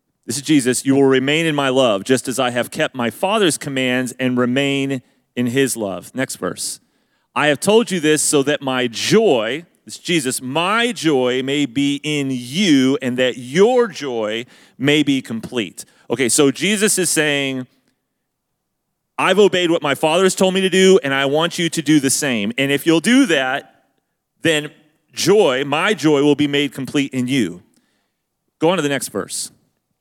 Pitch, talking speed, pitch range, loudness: 140 Hz, 185 wpm, 130-165 Hz, -17 LUFS